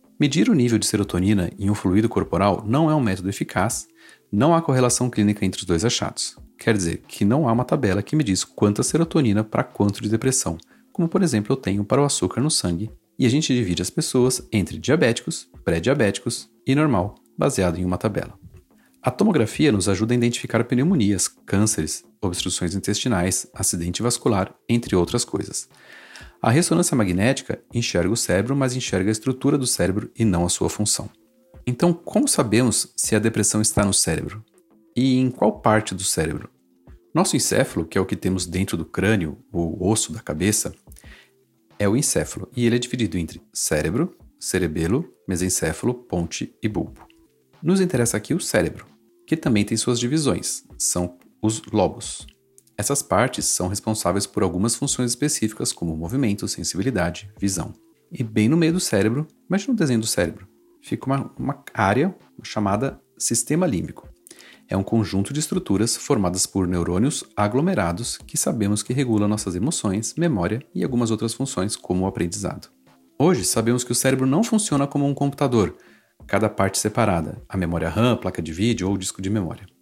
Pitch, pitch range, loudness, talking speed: 110 Hz, 95-125 Hz, -22 LUFS, 170 wpm